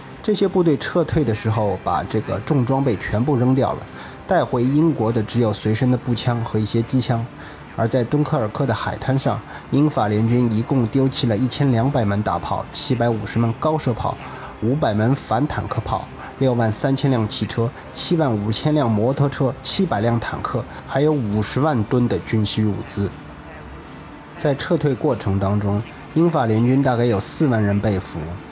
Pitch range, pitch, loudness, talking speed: 110-140 Hz, 120 Hz, -20 LUFS, 270 characters per minute